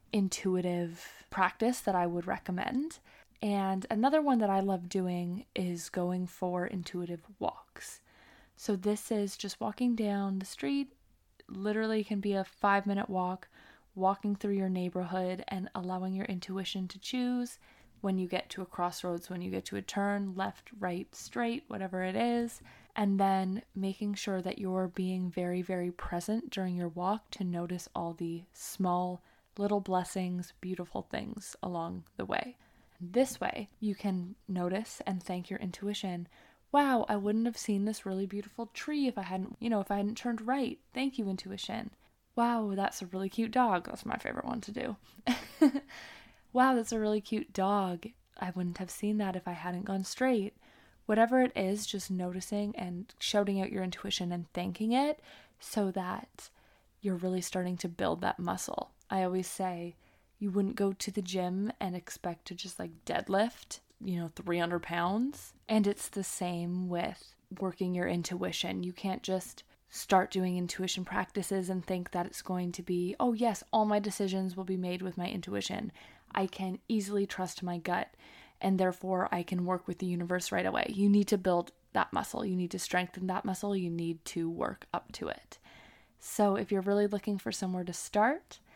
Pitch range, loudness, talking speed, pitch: 180-210 Hz, -34 LUFS, 180 wpm, 190 Hz